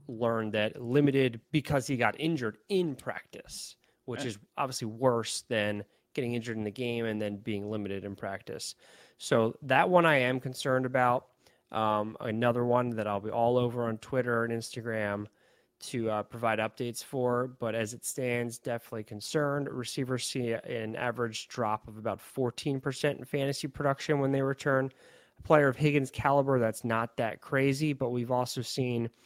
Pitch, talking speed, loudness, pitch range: 120 Hz, 170 wpm, -31 LUFS, 115-135 Hz